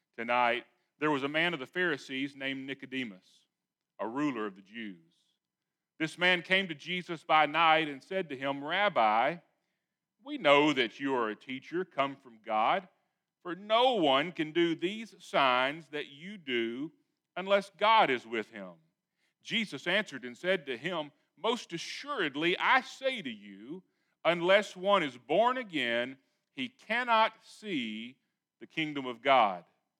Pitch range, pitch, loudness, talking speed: 135-205 Hz, 170 Hz, -30 LUFS, 150 wpm